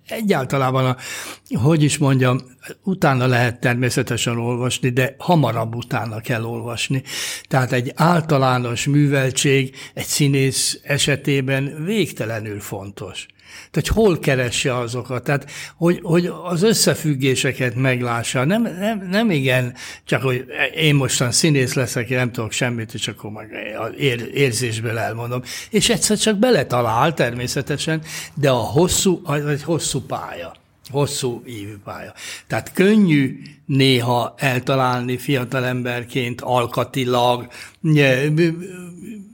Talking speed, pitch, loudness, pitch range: 115 wpm, 135 Hz, -19 LUFS, 125-155 Hz